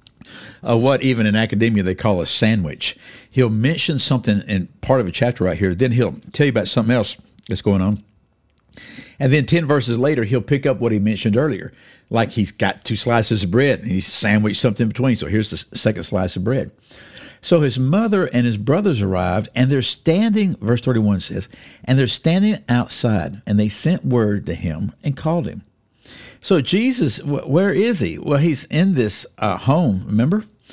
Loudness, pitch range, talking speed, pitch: -18 LUFS, 105-145 Hz, 195 wpm, 120 Hz